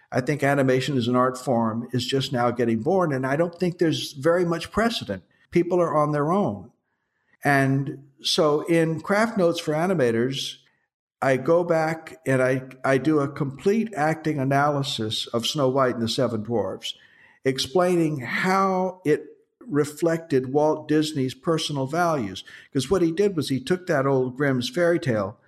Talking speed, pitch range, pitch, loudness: 165 wpm, 130-170 Hz, 145 Hz, -23 LUFS